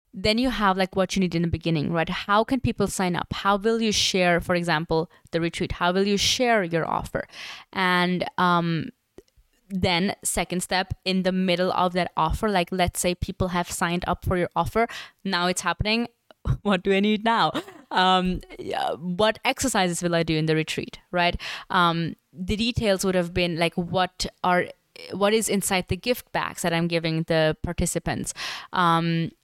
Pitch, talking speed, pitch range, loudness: 180 Hz, 185 wpm, 175-200 Hz, -24 LUFS